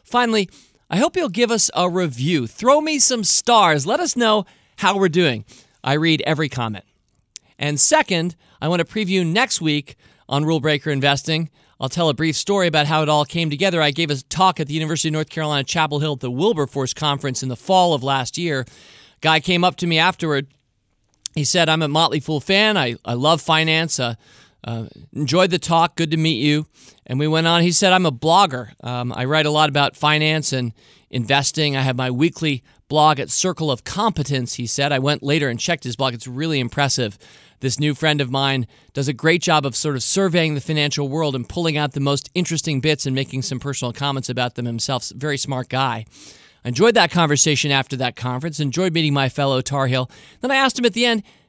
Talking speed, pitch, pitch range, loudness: 215 wpm, 150 Hz, 135-165 Hz, -19 LUFS